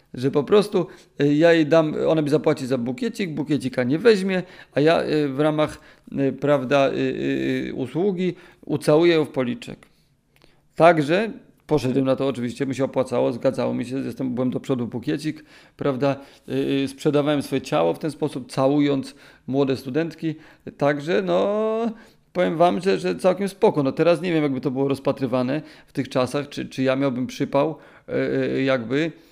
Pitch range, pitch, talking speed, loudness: 130-165 Hz, 145 Hz, 150 wpm, -22 LUFS